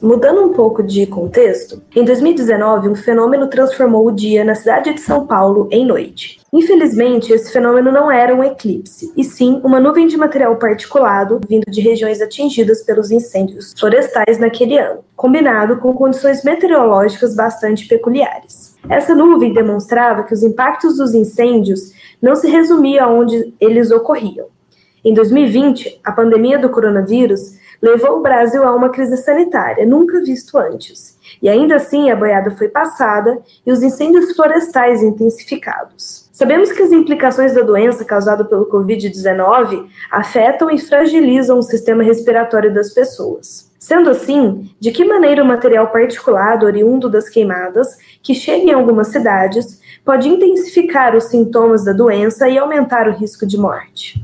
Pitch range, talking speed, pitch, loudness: 220-280 Hz, 150 wpm, 240 Hz, -12 LUFS